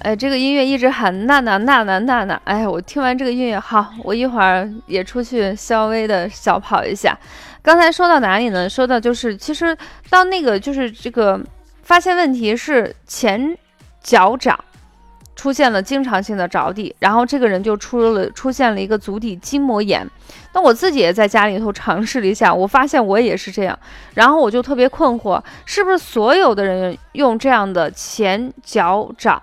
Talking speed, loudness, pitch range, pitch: 275 characters per minute, -16 LUFS, 200-265 Hz, 235 Hz